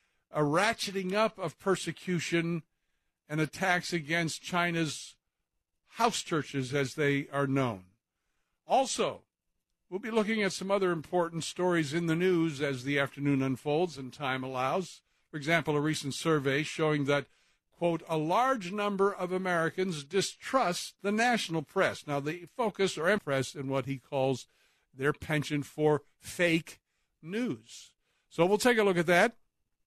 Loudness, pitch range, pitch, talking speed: -30 LUFS, 145-185 Hz, 165 Hz, 145 wpm